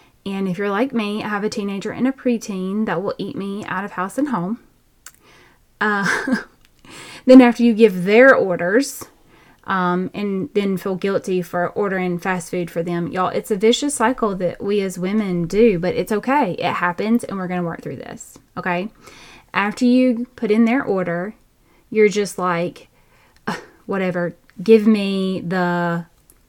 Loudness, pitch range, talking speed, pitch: -19 LUFS, 180-225 Hz, 170 wpm, 200 Hz